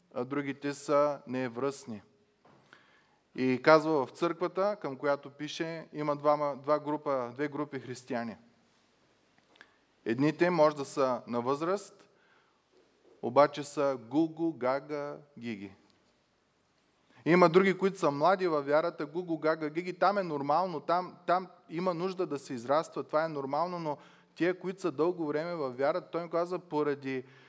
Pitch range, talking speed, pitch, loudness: 140-170 Hz, 140 wpm, 150 Hz, -31 LUFS